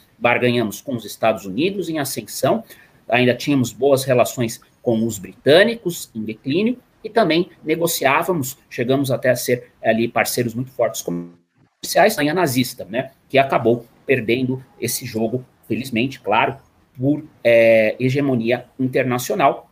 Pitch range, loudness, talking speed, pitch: 115-140 Hz, -19 LUFS, 130 wpm, 125 Hz